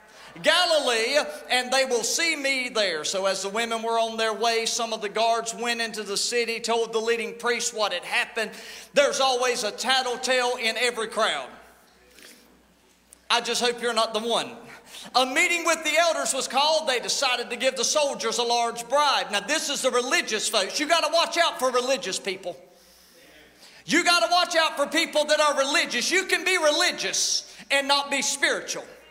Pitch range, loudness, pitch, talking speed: 225-295 Hz, -23 LUFS, 245 Hz, 190 wpm